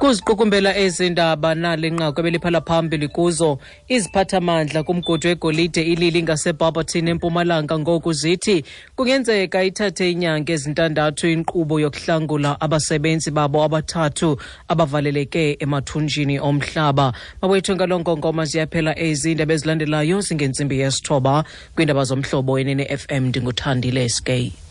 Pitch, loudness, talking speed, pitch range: 160 Hz, -19 LUFS, 90 wpm, 150-170 Hz